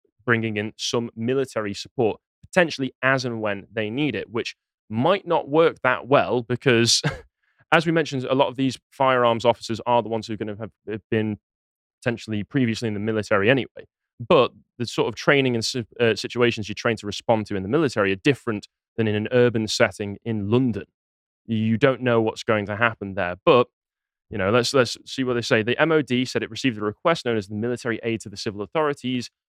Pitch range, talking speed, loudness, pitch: 110-125 Hz, 205 wpm, -23 LUFS, 115 Hz